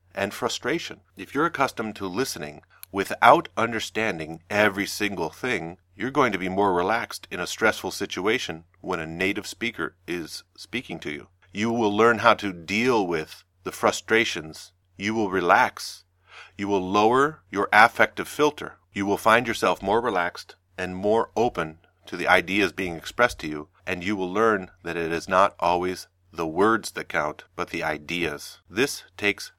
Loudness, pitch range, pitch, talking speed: -24 LUFS, 90-110 Hz, 95 Hz, 170 wpm